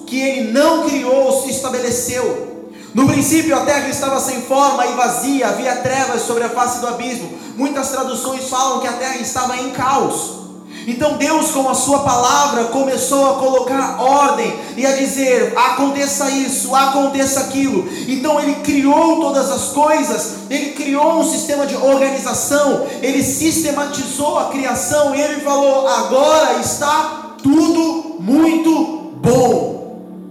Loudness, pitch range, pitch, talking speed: -15 LUFS, 255-290 Hz, 270 Hz, 145 wpm